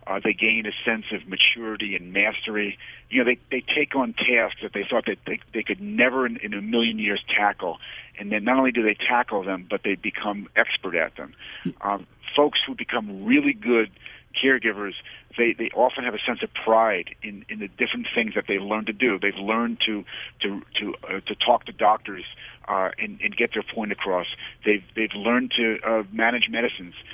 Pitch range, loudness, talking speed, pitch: 105-120 Hz, -23 LUFS, 205 wpm, 110 Hz